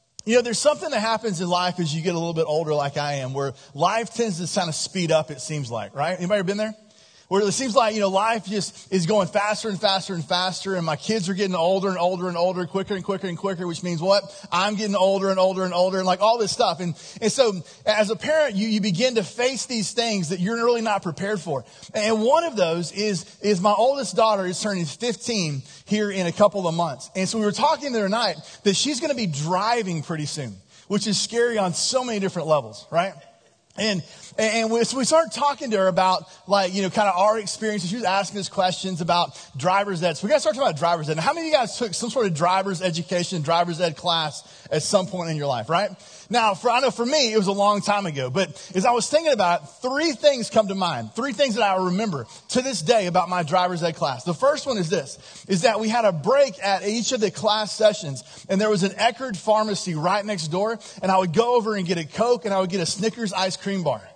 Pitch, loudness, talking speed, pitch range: 195 Hz, -22 LUFS, 260 wpm, 175-220 Hz